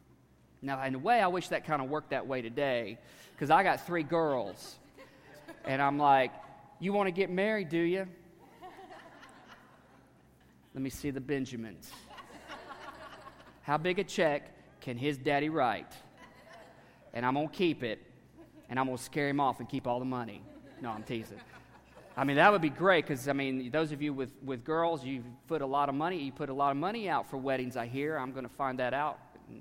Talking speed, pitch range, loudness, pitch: 205 wpm, 130-155 Hz, -32 LUFS, 140 Hz